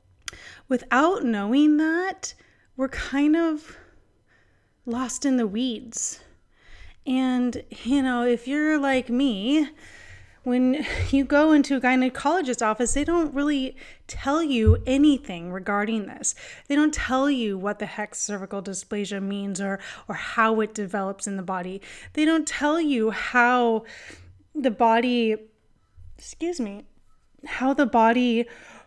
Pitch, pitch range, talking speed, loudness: 245 Hz, 210-280 Hz, 130 wpm, -24 LUFS